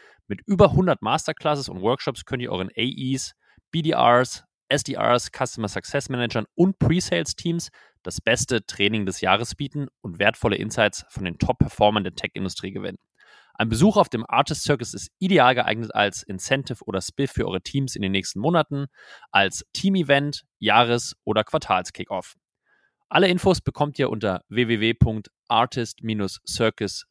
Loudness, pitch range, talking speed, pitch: -23 LUFS, 105-145 Hz, 150 wpm, 125 Hz